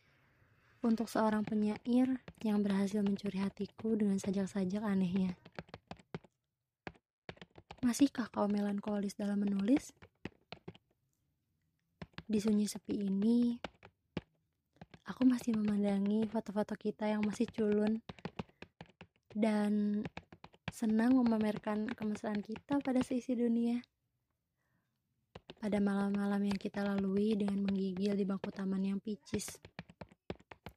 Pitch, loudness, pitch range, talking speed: 210 Hz, -35 LUFS, 200-220 Hz, 90 wpm